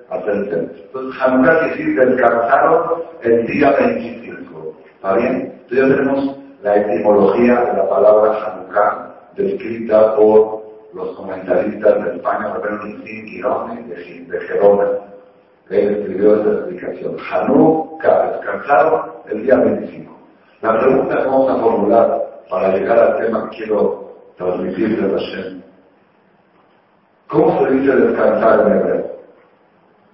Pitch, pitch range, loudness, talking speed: 120 Hz, 105-140 Hz, -15 LUFS, 120 wpm